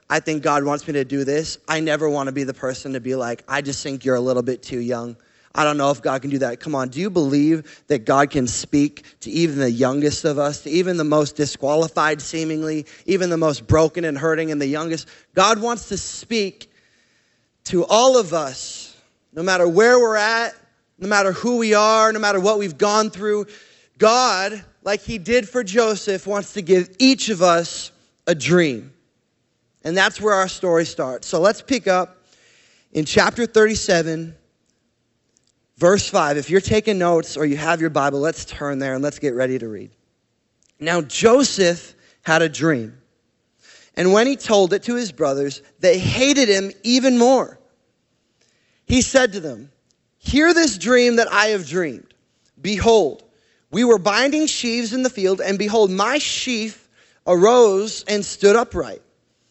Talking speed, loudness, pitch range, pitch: 180 wpm, -19 LUFS, 145-215 Hz, 175 Hz